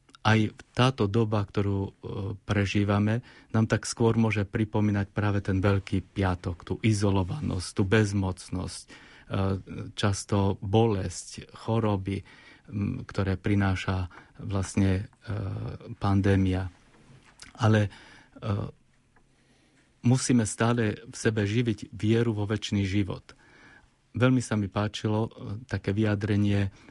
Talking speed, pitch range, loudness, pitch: 90 wpm, 100-115 Hz, -28 LUFS, 105 Hz